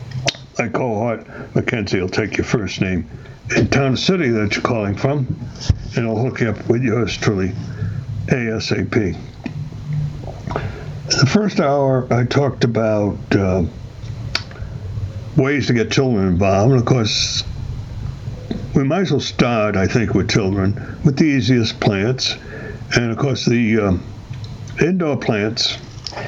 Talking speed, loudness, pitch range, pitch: 135 wpm, -18 LUFS, 110-130 Hz, 120 Hz